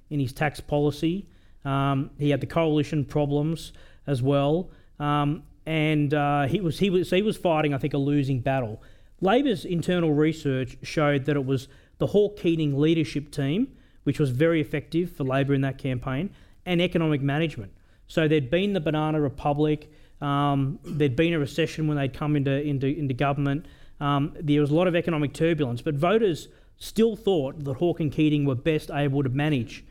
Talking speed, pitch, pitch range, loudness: 180 wpm, 150 Hz, 140-160 Hz, -25 LUFS